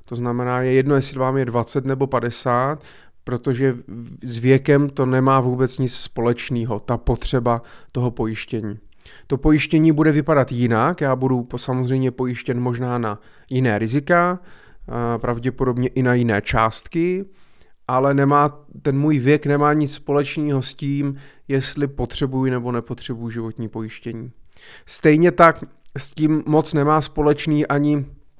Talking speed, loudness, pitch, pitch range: 135 wpm, -20 LUFS, 130 Hz, 120-145 Hz